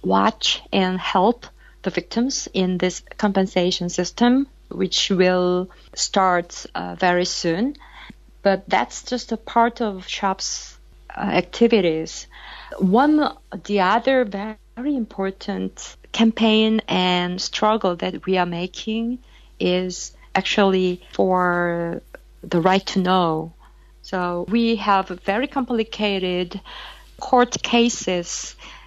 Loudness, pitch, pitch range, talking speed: -21 LUFS, 190 Hz, 180-230 Hz, 105 wpm